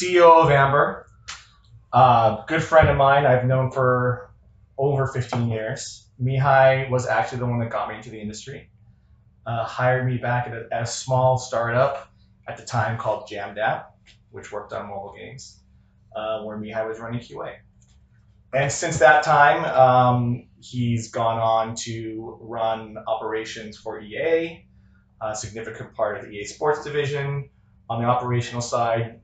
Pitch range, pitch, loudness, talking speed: 110-135 Hz, 120 Hz, -21 LUFS, 160 wpm